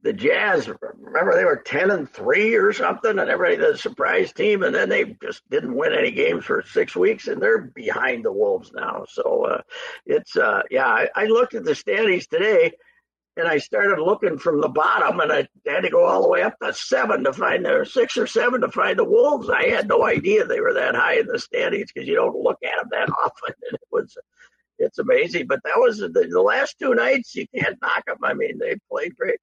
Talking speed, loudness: 230 wpm, -20 LUFS